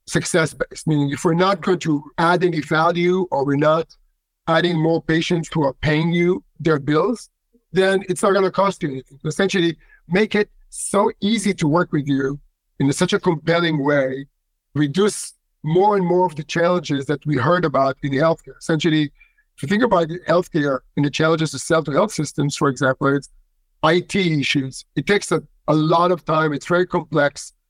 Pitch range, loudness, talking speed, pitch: 145-180 Hz, -19 LUFS, 190 wpm, 160 Hz